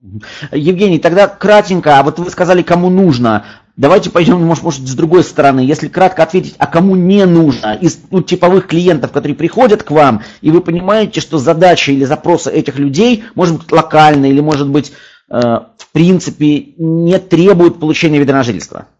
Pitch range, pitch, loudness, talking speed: 145-180 Hz, 165 Hz, -10 LUFS, 170 wpm